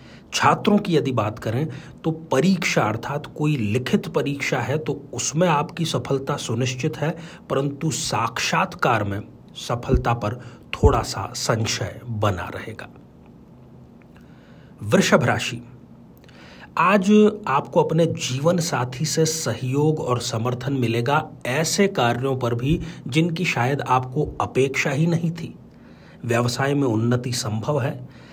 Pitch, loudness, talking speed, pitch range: 135 Hz, -22 LUFS, 120 wpm, 120-160 Hz